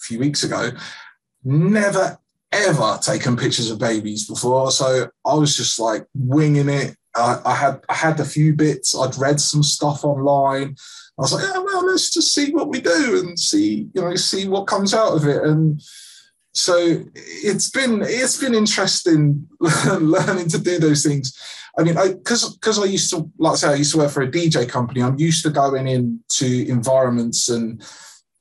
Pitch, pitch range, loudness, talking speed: 150 Hz, 130-185 Hz, -18 LUFS, 190 wpm